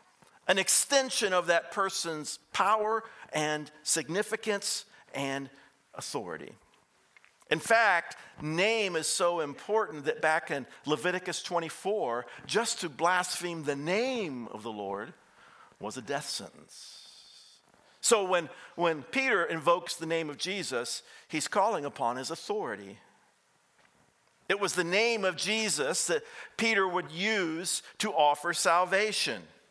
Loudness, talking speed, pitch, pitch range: -29 LUFS, 120 wpm, 180 Hz, 165-215 Hz